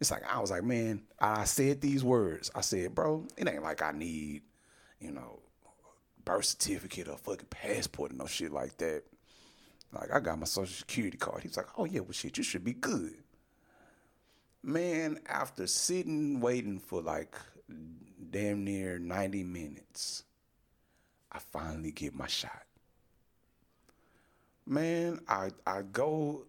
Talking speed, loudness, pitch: 150 wpm, -35 LUFS, 100 Hz